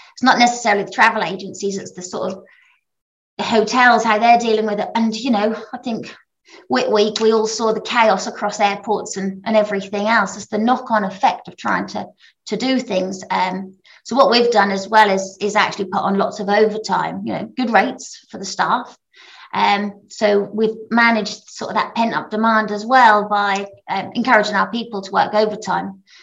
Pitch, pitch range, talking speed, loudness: 215 Hz, 200-230 Hz, 200 wpm, -17 LUFS